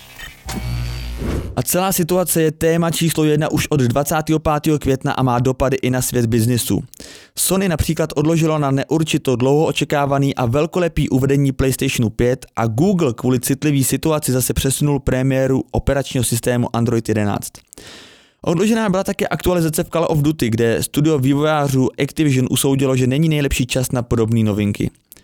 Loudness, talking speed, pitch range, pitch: -17 LUFS, 145 wpm, 125-155 Hz, 140 Hz